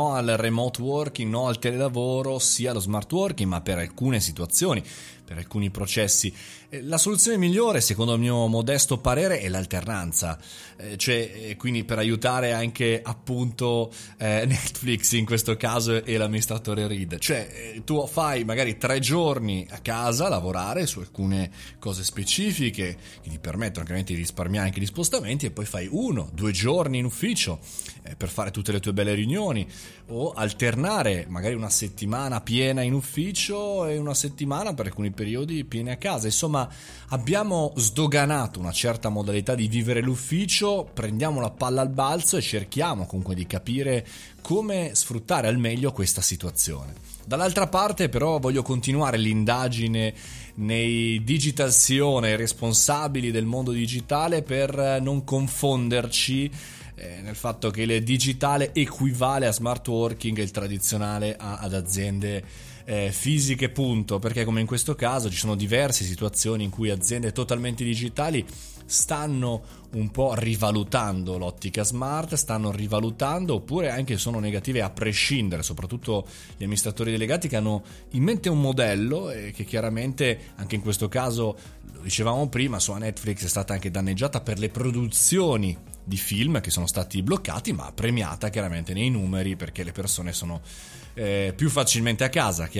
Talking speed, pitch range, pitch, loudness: 150 wpm, 105-135 Hz, 115 Hz, -25 LUFS